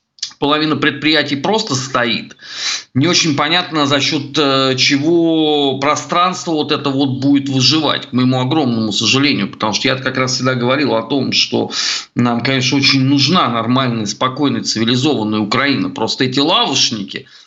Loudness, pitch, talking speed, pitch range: -14 LUFS, 140 Hz, 140 wpm, 130-150 Hz